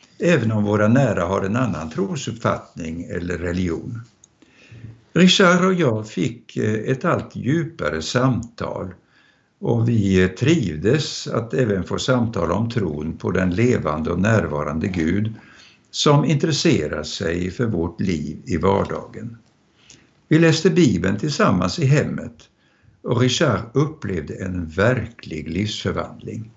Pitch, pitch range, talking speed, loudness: 110 Hz, 95-125 Hz, 120 wpm, -20 LUFS